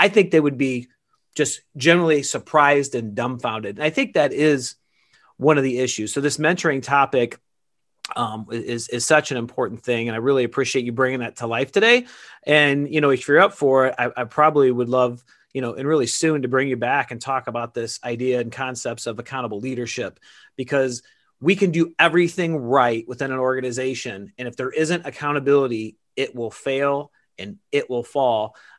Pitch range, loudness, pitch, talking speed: 120-145 Hz, -21 LUFS, 130 Hz, 195 wpm